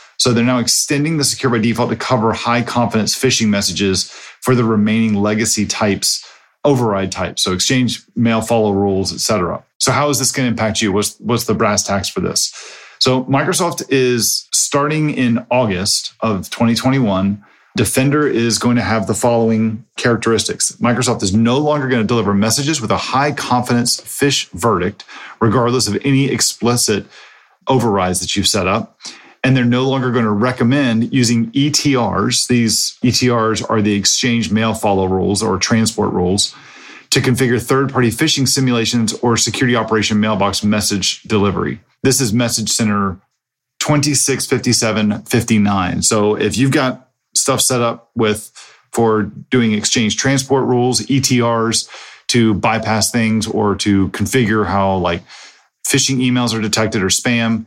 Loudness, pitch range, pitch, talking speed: -15 LUFS, 105-130 Hz, 115 Hz, 150 wpm